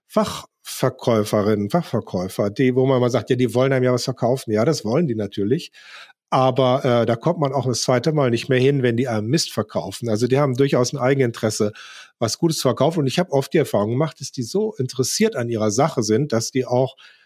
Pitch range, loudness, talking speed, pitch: 115-140 Hz, -20 LUFS, 225 wpm, 130 Hz